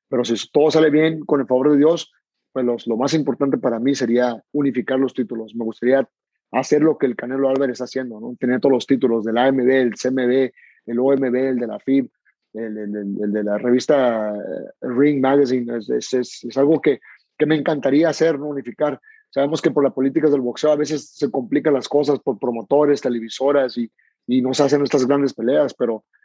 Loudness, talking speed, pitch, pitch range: -19 LUFS, 210 wpm, 130 Hz, 120-145 Hz